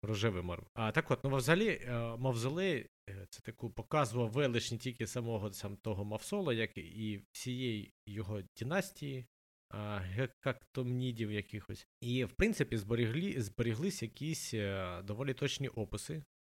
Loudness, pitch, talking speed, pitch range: -38 LUFS, 115 Hz, 125 wpm, 105-135 Hz